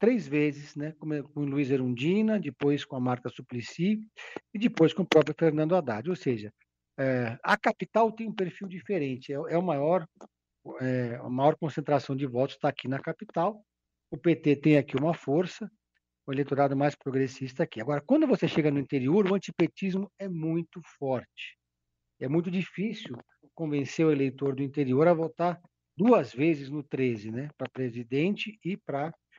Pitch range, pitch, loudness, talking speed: 135-180 Hz, 150 Hz, -29 LUFS, 170 wpm